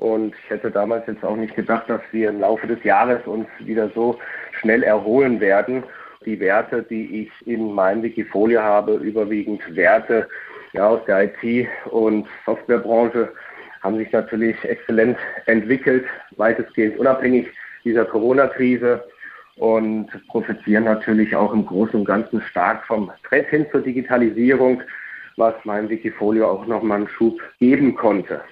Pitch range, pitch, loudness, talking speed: 110-120 Hz, 110 Hz, -19 LUFS, 145 wpm